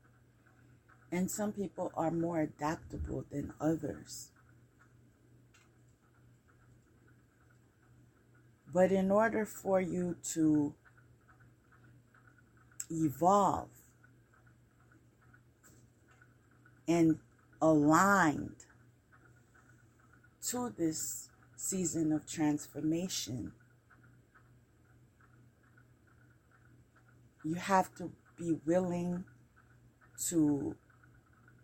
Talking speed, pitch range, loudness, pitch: 55 wpm, 120-155 Hz, -33 LUFS, 120 Hz